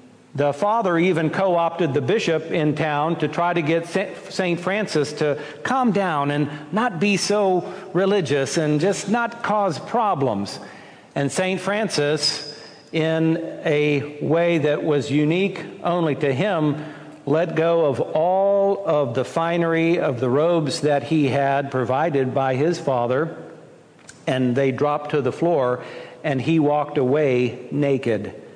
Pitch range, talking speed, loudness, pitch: 145-180 Hz, 145 wpm, -21 LUFS, 155 Hz